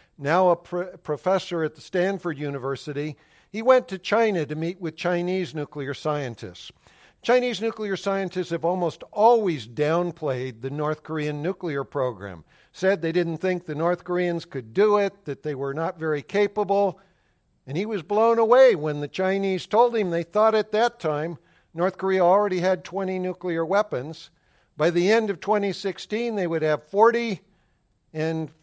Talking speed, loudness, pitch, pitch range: 165 wpm, -24 LUFS, 175 Hz, 155-195 Hz